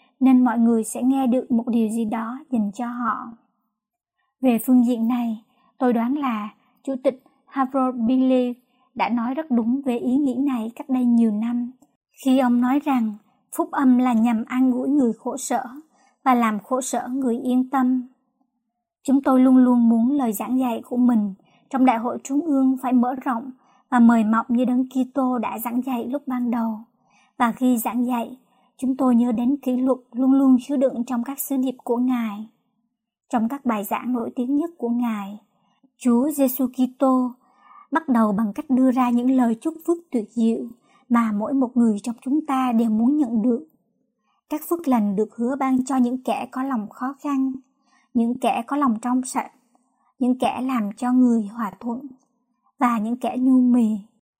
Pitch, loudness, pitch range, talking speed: 250 Hz, -22 LUFS, 235-260 Hz, 190 wpm